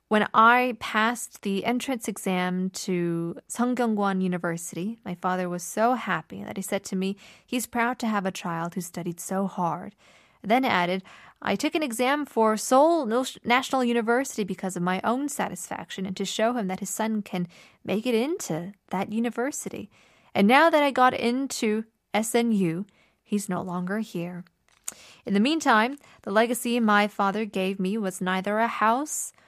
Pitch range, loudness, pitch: 185-235 Hz, -26 LUFS, 210 Hz